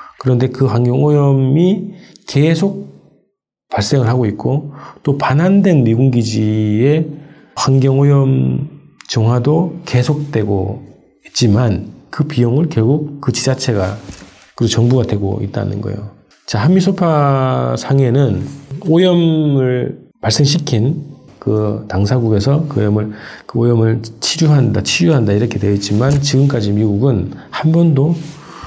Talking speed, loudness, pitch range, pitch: 255 characters per minute, -14 LUFS, 110-150 Hz, 130 Hz